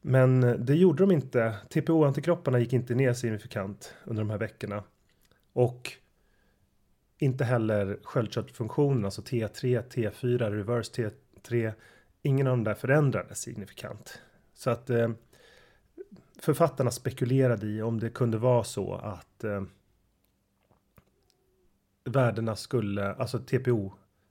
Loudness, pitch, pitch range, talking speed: -28 LUFS, 120 Hz, 105-130 Hz, 110 wpm